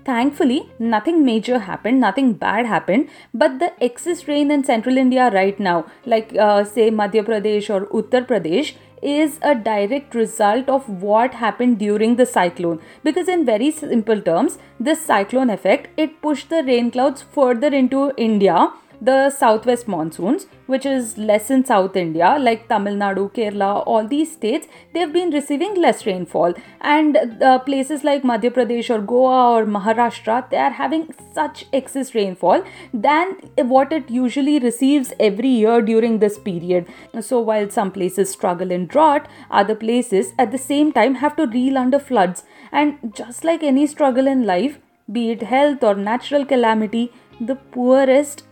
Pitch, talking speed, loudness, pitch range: 245 Hz, 160 wpm, -18 LUFS, 215-285 Hz